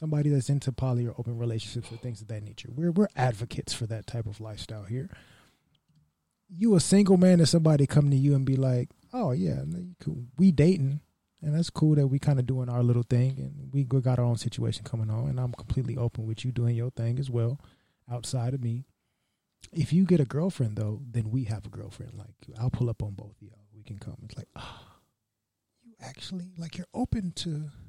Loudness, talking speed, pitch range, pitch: -27 LUFS, 220 wpm, 115-150 Hz, 125 Hz